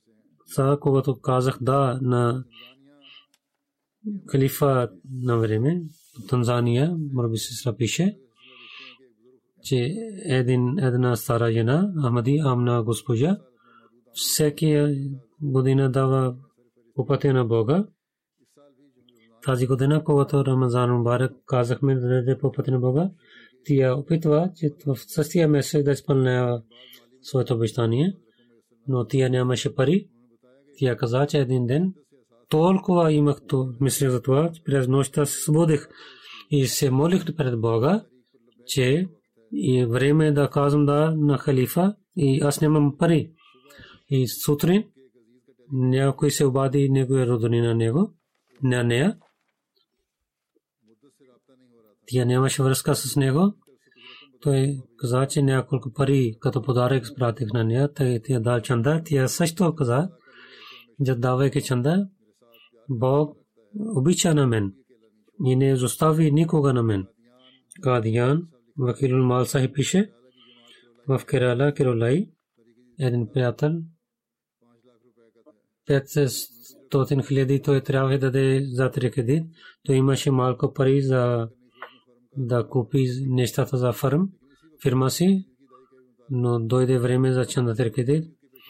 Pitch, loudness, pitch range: 135 Hz, -23 LUFS, 125-145 Hz